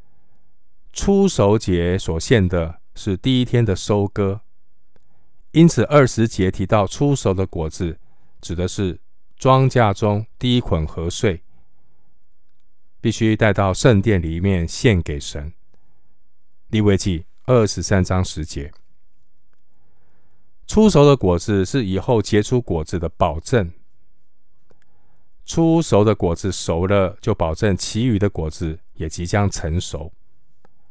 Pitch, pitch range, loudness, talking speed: 95 Hz, 85-110 Hz, -19 LUFS, 175 characters per minute